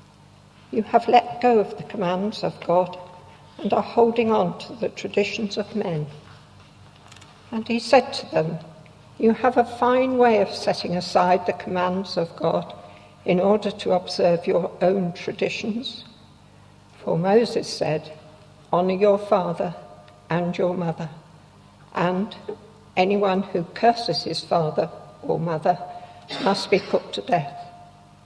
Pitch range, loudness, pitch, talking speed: 170-215 Hz, -23 LUFS, 185 Hz, 135 wpm